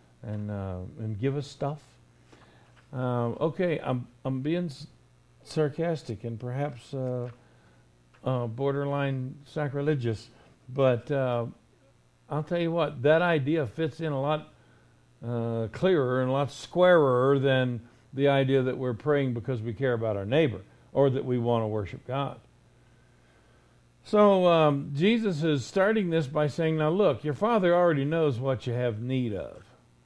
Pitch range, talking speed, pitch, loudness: 120-150 Hz, 150 wpm, 135 Hz, -27 LUFS